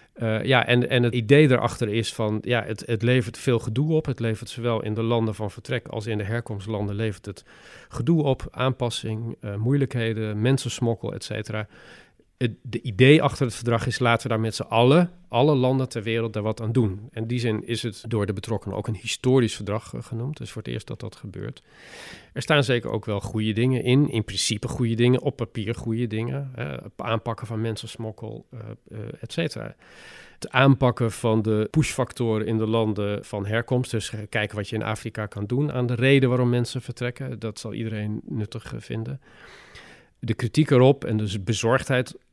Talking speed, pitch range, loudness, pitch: 195 wpm, 110-125 Hz, -24 LUFS, 115 Hz